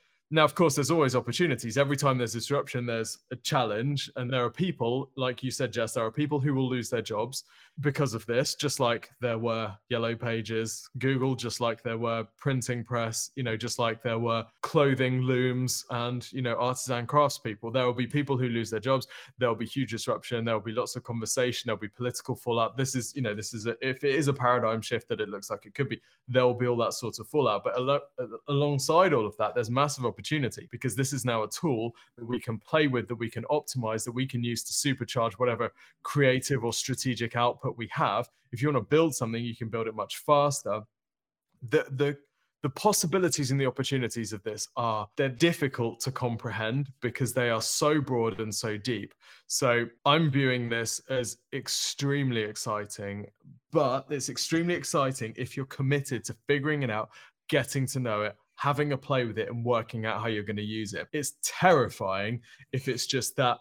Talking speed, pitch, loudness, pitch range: 210 wpm, 125 Hz, -29 LUFS, 115-140 Hz